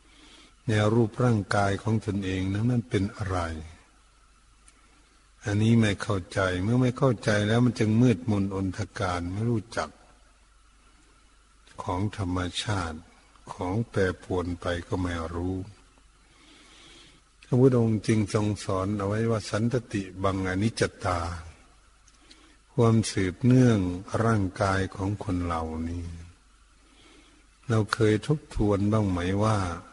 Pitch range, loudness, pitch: 90-110 Hz, -27 LUFS, 100 Hz